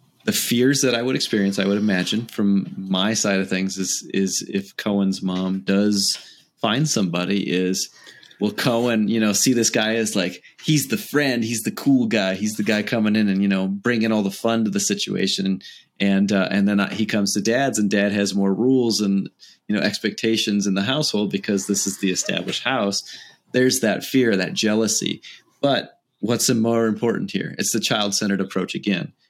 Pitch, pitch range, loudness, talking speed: 105 Hz, 100-115 Hz, -21 LUFS, 195 wpm